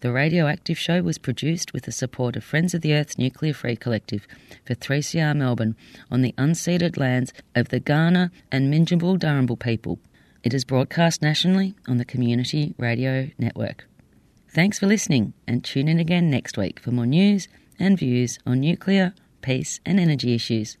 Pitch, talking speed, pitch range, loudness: 135 Hz, 175 wpm, 120-165 Hz, -22 LUFS